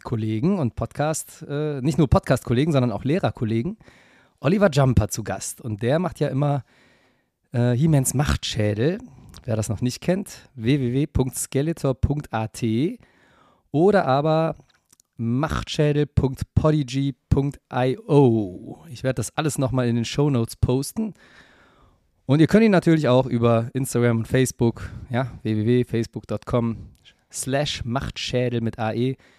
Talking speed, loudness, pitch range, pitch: 115 wpm, -22 LUFS, 115-145 Hz, 130 Hz